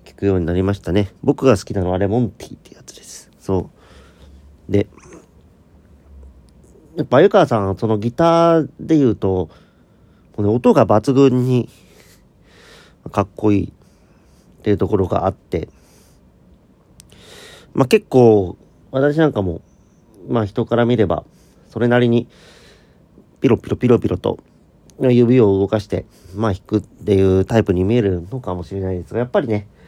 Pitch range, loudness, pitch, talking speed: 90-120 Hz, -17 LUFS, 105 Hz, 280 characters per minute